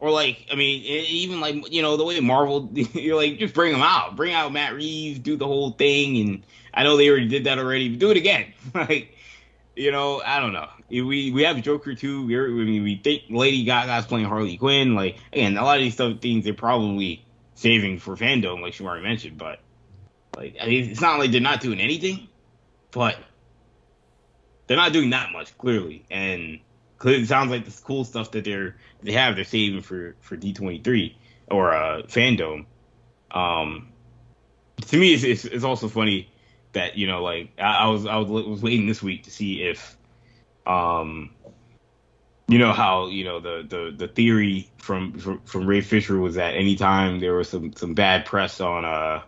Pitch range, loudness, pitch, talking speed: 100-135 Hz, -22 LUFS, 115 Hz, 200 wpm